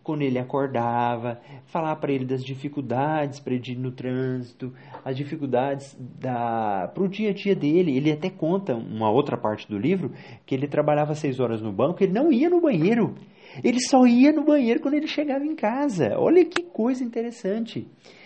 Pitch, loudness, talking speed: 145 Hz, -24 LUFS, 185 wpm